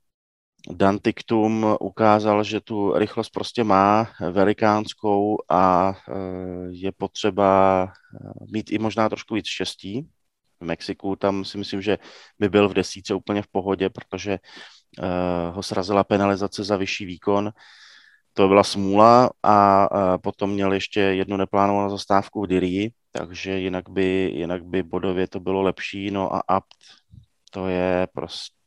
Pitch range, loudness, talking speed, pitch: 95-105 Hz, -22 LUFS, 140 wpm, 100 Hz